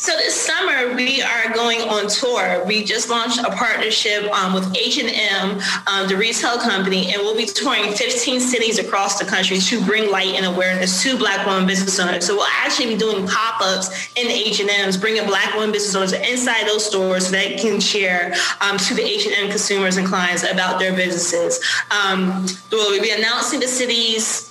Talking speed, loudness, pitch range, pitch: 190 wpm, -17 LUFS, 190-230 Hz, 205 Hz